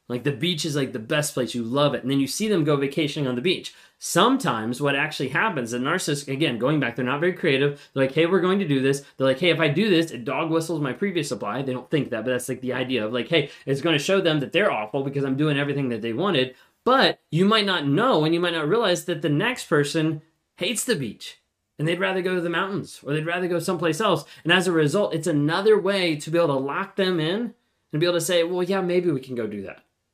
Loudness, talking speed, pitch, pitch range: -23 LUFS, 275 wpm, 155 Hz, 135-175 Hz